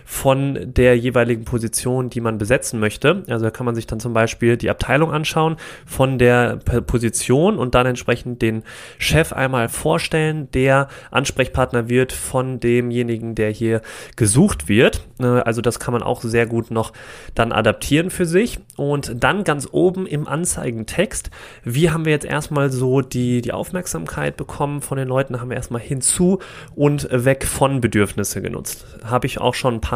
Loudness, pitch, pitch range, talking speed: -19 LUFS, 125 Hz, 115-140 Hz, 170 wpm